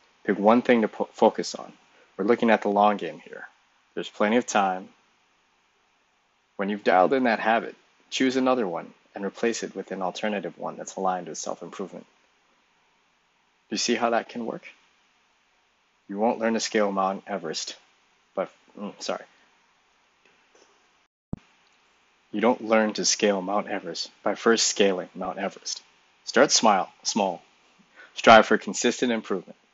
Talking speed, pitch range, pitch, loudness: 150 wpm, 95-115 Hz, 105 Hz, -24 LUFS